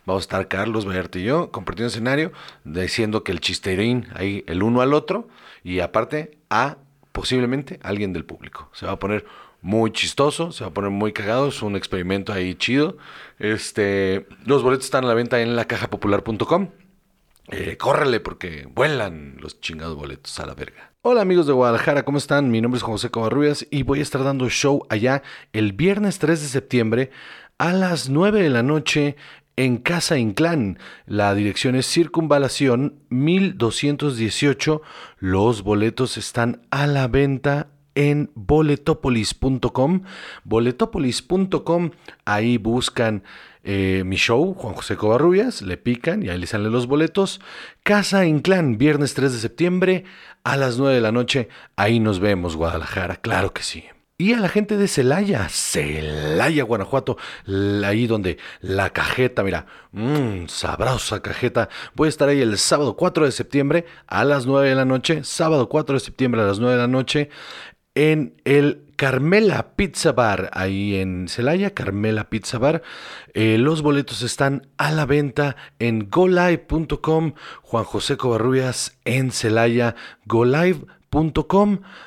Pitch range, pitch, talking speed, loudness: 105-150 Hz, 125 Hz, 155 wpm, -20 LUFS